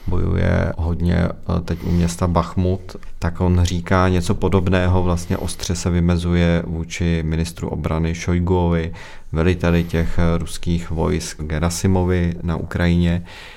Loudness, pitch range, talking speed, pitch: -20 LUFS, 85-90 Hz, 115 wpm, 85 Hz